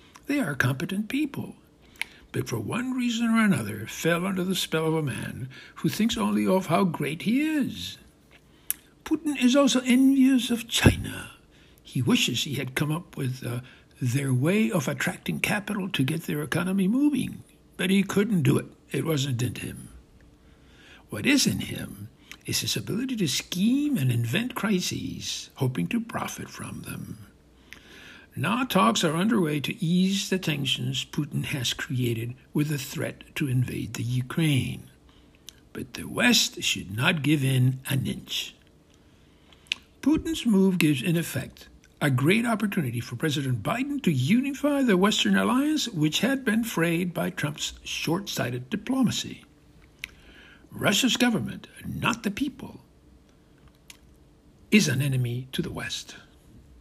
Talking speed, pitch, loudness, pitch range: 145 wpm, 170 Hz, -26 LUFS, 130-220 Hz